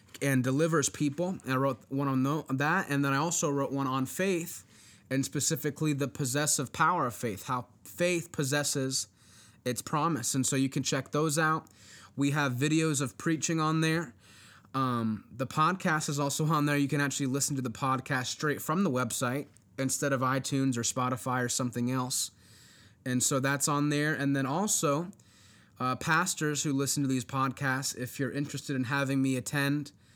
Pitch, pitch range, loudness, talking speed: 135 Hz, 125-150 Hz, -30 LUFS, 180 wpm